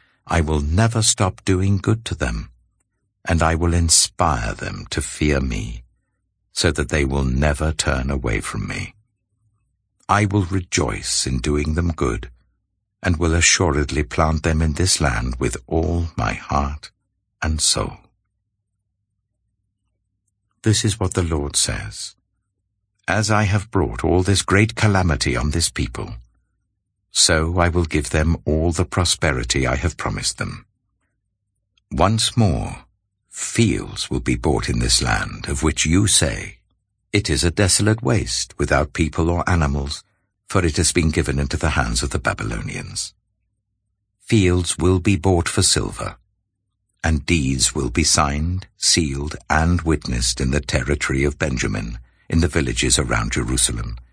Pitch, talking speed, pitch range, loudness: 90 Hz, 145 wpm, 75-105 Hz, -19 LUFS